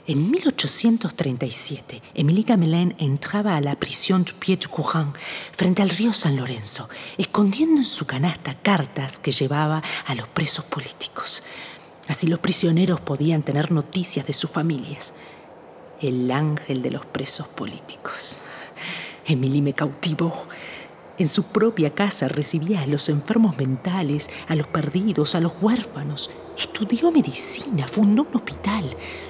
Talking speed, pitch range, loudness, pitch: 130 wpm, 145-195 Hz, -22 LUFS, 165 Hz